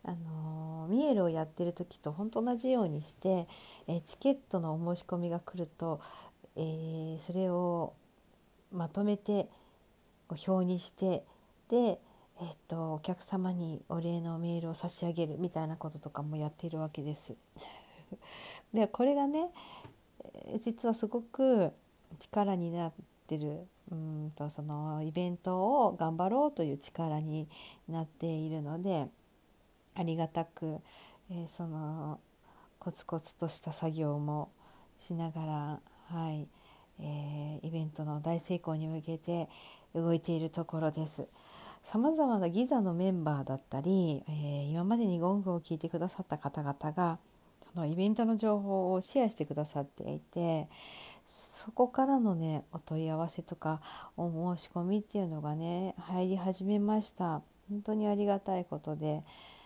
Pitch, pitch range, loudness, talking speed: 170 Hz, 155-190 Hz, -35 LUFS, 285 characters per minute